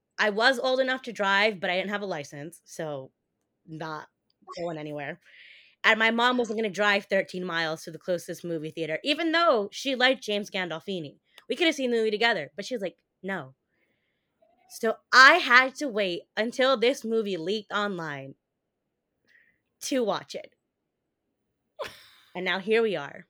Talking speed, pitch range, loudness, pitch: 170 wpm, 170-245 Hz, -25 LUFS, 205 Hz